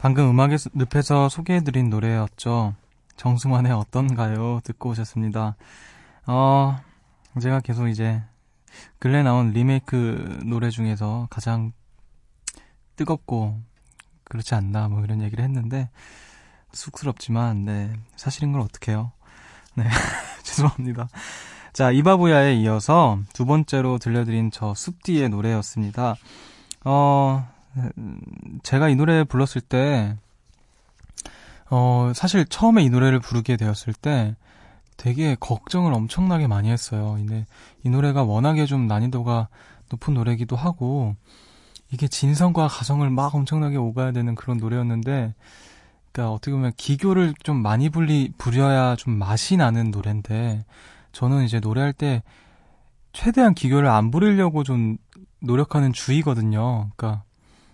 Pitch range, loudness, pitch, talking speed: 110-140 Hz, -22 LUFS, 125 Hz, 275 characters per minute